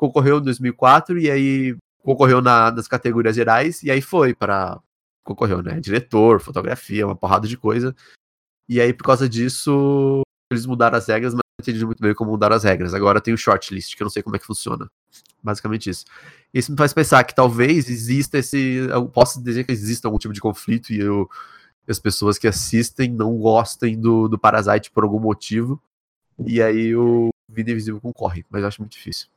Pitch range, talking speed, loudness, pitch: 110-125 Hz, 200 wpm, -19 LUFS, 115 Hz